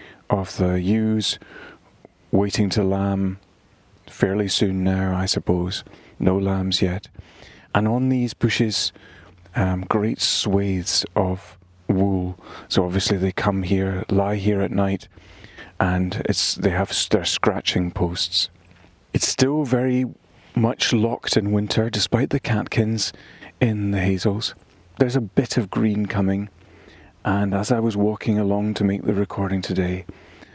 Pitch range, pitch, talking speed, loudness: 95-105 Hz, 100 Hz, 135 wpm, -22 LUFS